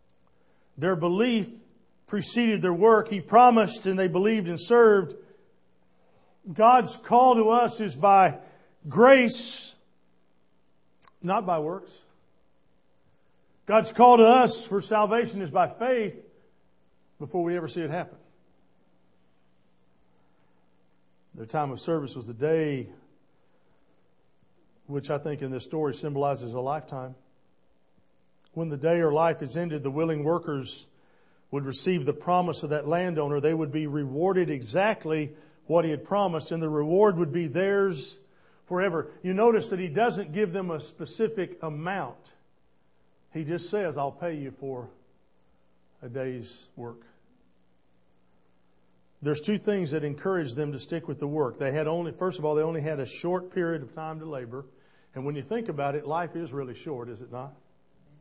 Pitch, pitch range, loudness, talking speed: 155 Hz, 120-185 Hz, -25 LUFS, 150 wpm